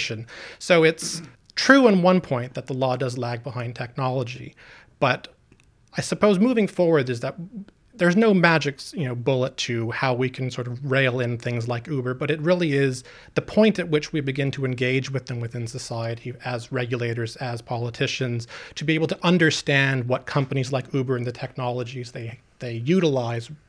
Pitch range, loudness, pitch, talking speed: 125-155 Hz, -23 LUFS, 130 Hz, 180 wpm